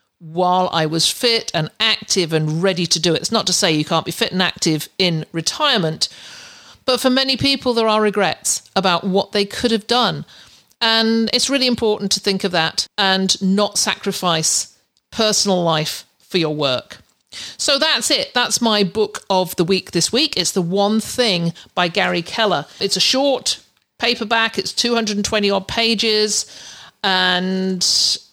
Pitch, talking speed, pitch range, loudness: 200 Hz, 165 wpm, 180-225 Hz, -17 LUFS